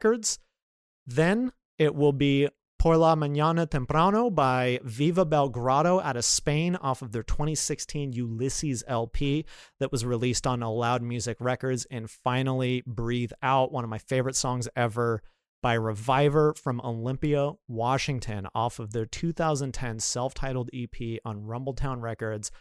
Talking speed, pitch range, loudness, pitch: 140 wpm, 120-145 Hz, -27 LUFS, 130 Hz